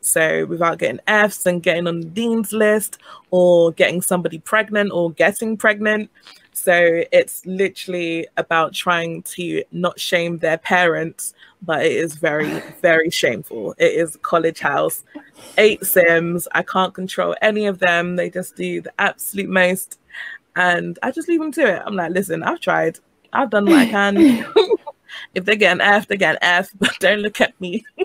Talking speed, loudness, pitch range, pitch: 175 wpm, -18 LUFS, 170-215 Hz, 185 Hz